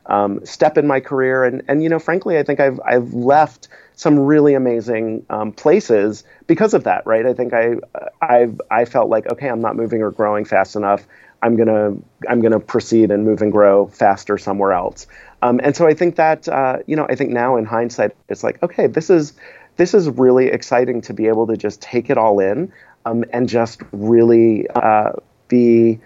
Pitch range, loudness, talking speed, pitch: 110-135 Hz, -16 LUFS, 205 wpm, 120 Hz